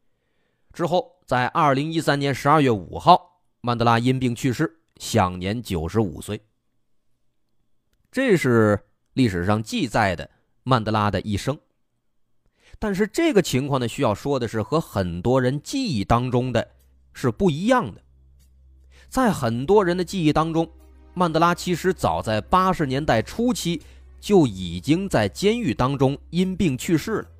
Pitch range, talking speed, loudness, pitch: 105-170 Hz, 220 characters per minute, -22 LUFS, 130 Hz